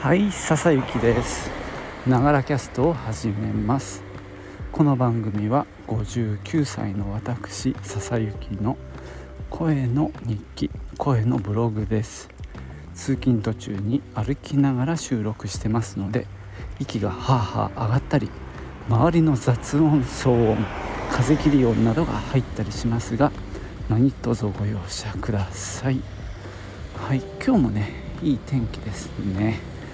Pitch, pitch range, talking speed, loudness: 110 Hz, 100-130 Hz, 230 characters per minute, -24 LUFS